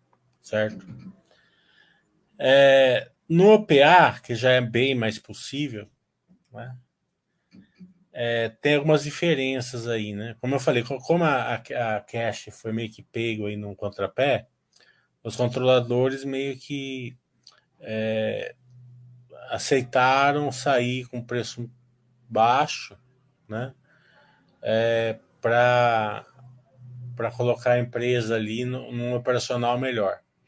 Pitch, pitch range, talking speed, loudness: 125 Hz, 115-135 Hz, 105 wpm, -23 LUFS